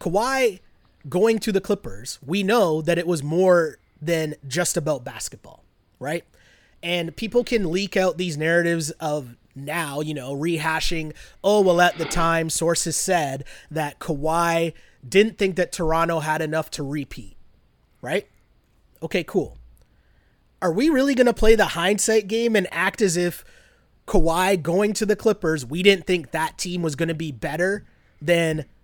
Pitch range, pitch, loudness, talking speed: 160-195 Hz, 170 Hz, -22 LUFS, 160 wpm